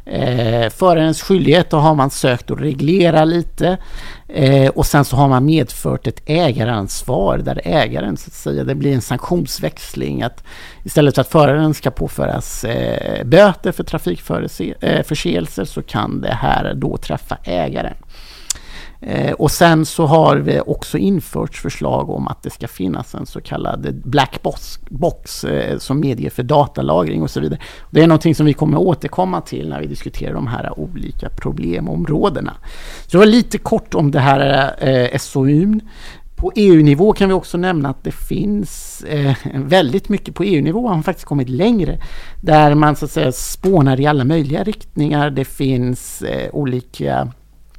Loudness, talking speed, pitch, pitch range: -16 LUFS, 165 wpm, 150 Hz, 135-170 Hz